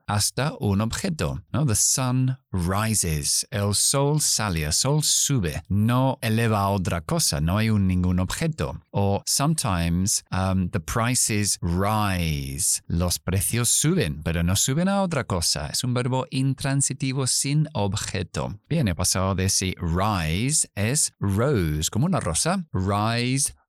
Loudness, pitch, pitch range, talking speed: -23 LUFS, 105 Hz, 90-130 Hz, 140 wpm